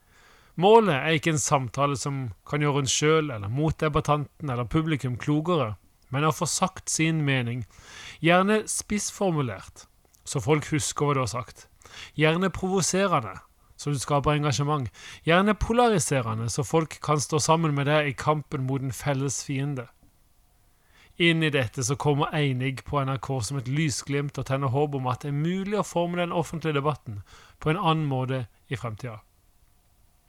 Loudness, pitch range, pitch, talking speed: -25 LUFS, 125-155 Hz, 145 Hz, 160 wpm